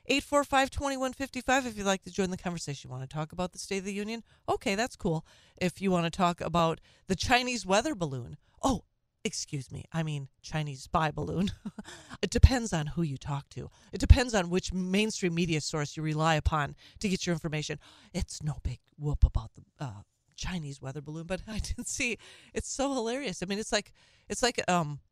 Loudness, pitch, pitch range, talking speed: -31 LUFS, 175 Hz, 150-205 Hz, 205 wpm